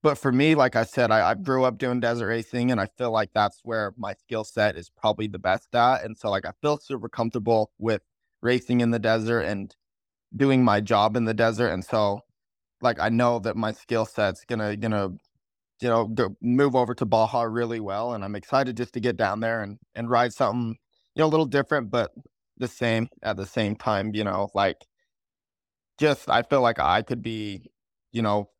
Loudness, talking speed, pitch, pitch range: -25 LUFS, 215 wpm, 115 Hz, 105-125 Hz